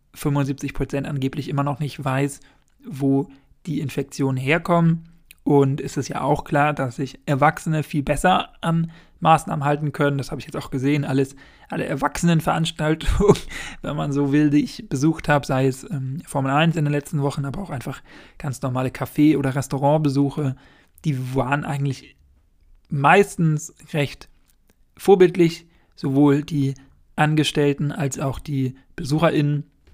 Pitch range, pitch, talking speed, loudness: 140-155 Hz, 145 Hz, 145 wpm, -21 LUFS